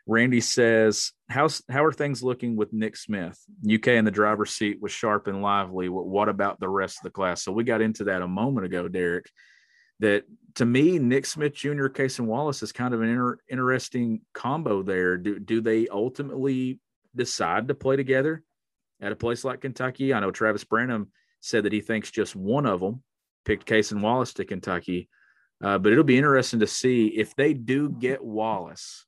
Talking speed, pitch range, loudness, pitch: 200 wpm, 105-130 Hz, -25 LUFS, 115 Hz